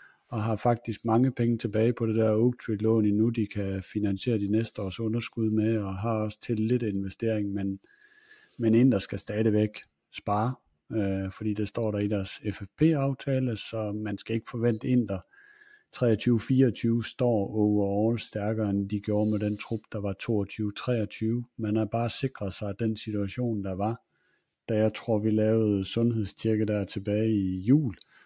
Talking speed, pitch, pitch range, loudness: 170 wpm, 110 Hz, 105-115 Hz, -28 LUFS